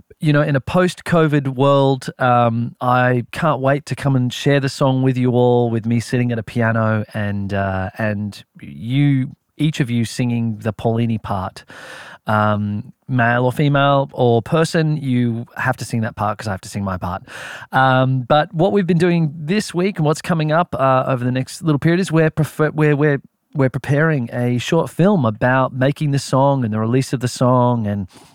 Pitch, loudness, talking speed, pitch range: 130 Hz, -18 LUFS, 200 wpm, 115-150 Hz